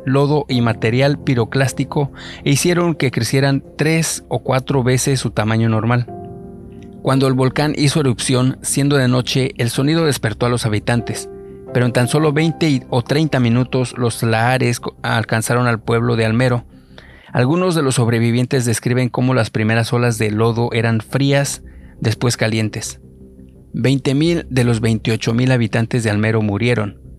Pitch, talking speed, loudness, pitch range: 125 Hz, 150 wpm, -17 LUFS, 115-135 Hz